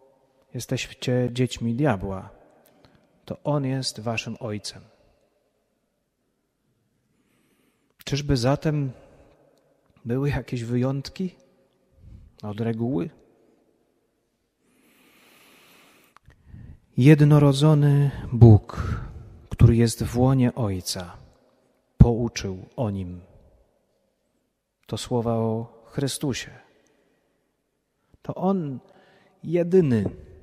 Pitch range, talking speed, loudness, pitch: 110-140 Hz, 65 wpm, -23 LUFS, 125 Hz